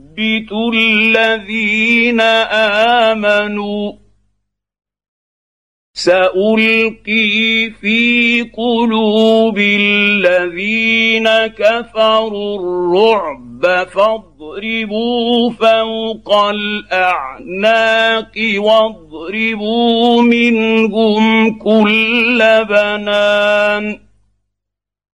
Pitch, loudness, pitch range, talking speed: 220 Hz, -12 LUFS, 205-225 Hz, 35 wpm